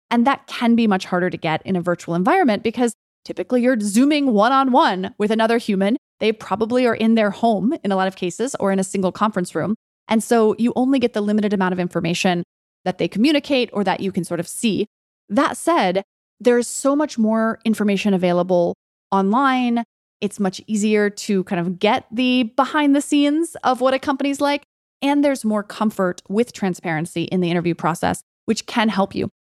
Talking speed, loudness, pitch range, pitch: 200 wpm, -19 LUFS, 185-250 Hz, 215 Hz